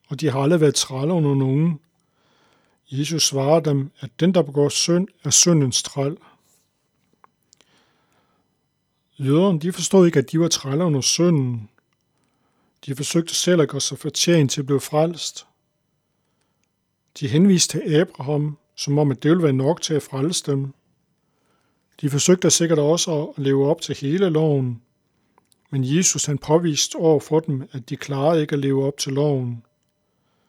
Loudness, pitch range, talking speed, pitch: -20 LUFS, 140-165 Hz, 160 wpm, 150 Hz